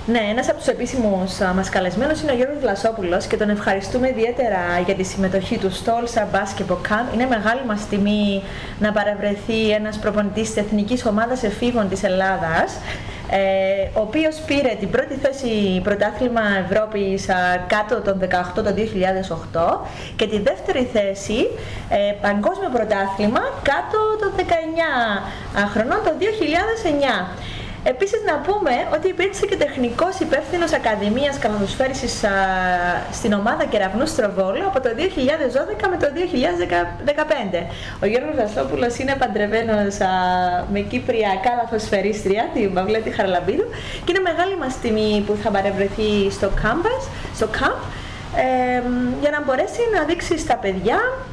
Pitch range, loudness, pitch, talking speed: 200-280 Hz, -20 LUFS, 220 Hz, 130 wpm